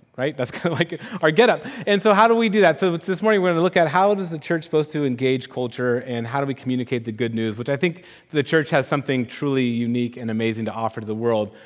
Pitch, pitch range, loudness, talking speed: 140 Hz, 120-180 Hz, -21 LUFS, 285 wpm